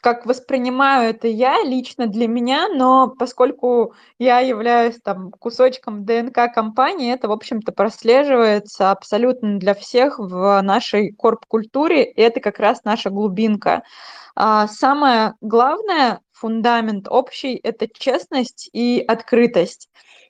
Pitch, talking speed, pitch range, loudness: 235 Hz, 115 wpm, 215-255 Hz, -17 LUFS